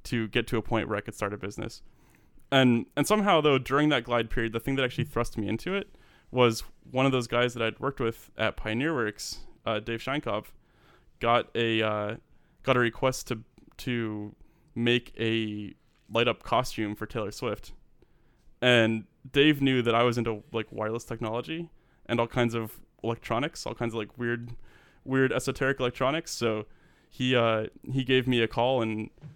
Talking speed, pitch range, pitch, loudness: 185 wpm, 110-130 Hz, 120 Hz, -28 LUFS